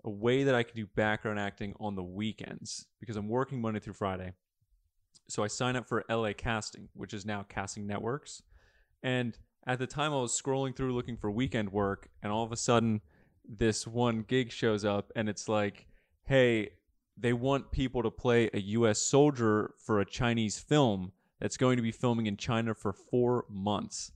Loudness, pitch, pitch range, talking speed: -32 LUFS, 110 Hz, 105-125 Hz, 190 wpm